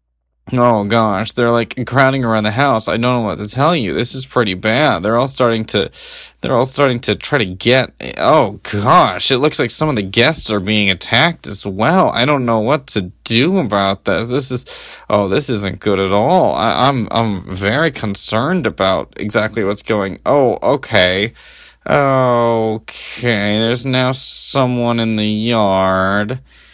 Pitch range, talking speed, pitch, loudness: 105-130 Hz, 175 wpm, 115 Hz, -14 LUFS